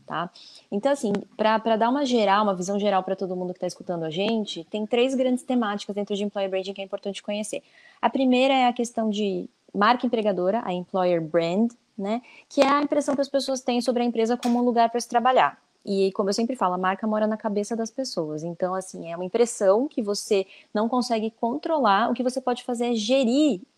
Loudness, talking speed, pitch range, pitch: -24 LUFS, 220 wpm, 200-250 Hz, 225 Hz